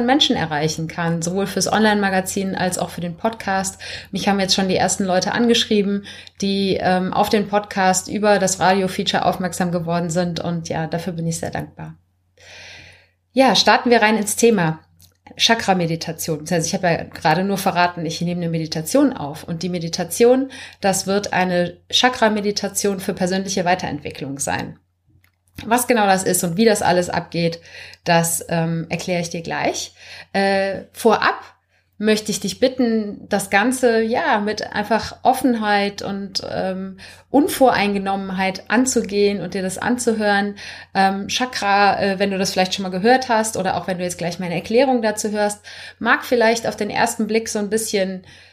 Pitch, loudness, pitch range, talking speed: 195 Hz, -19 LUFS, 175-215 Hz, 165 wpm